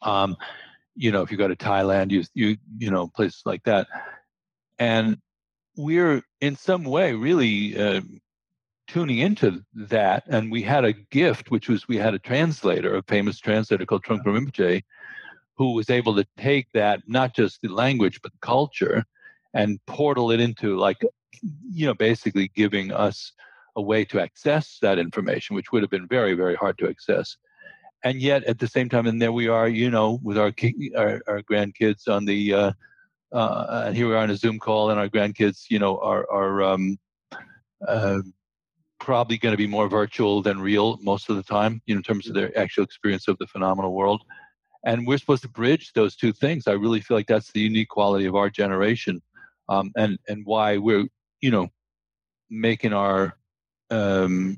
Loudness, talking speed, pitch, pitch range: -23 LUFS, 190 wpm, 110 Hz, 100-120 Hz